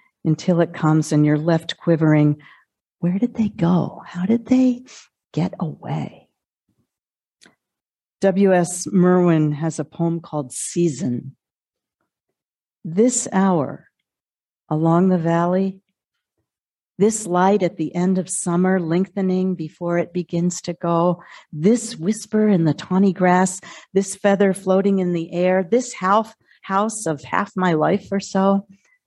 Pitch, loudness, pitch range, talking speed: 180 Hz, -20 LUFS, 170-195 Hz, 130 wpm